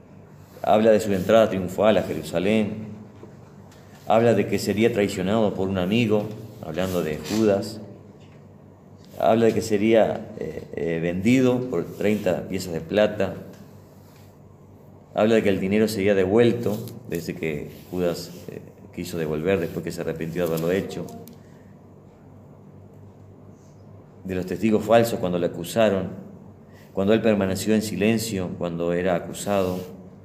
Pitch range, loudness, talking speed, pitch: 90-110 Hz, -23 LUFS, 130 wpm, 100 Hz